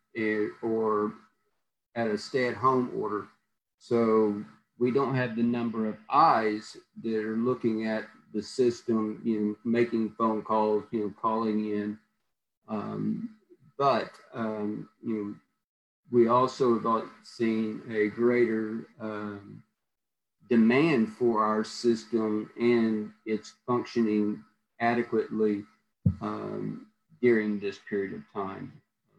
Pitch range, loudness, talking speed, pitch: 105-120 Hz, -28 LUFS, 110 wpm, 110 Hz